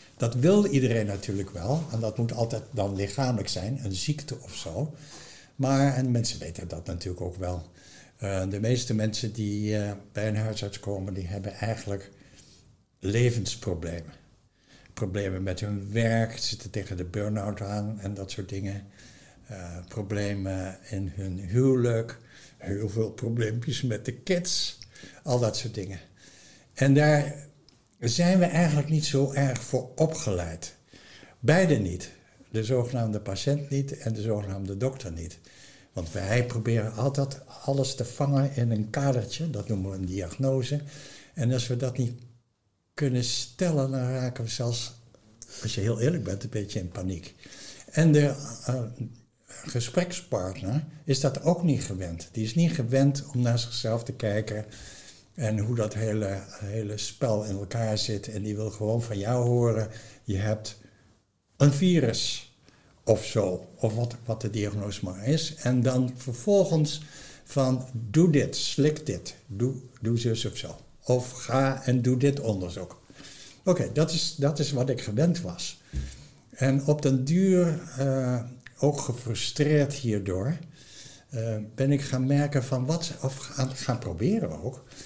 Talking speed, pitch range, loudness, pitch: 155 wpm, 105-135 Hz, -28 LUFS, 120 Hz